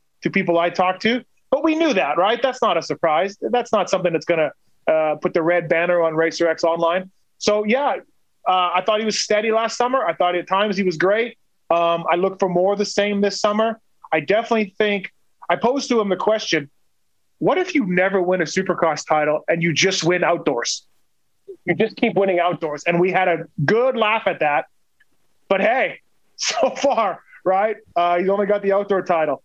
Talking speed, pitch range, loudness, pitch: 210 wpm, 170-215 Hz, -20 LUFS, 185 Hz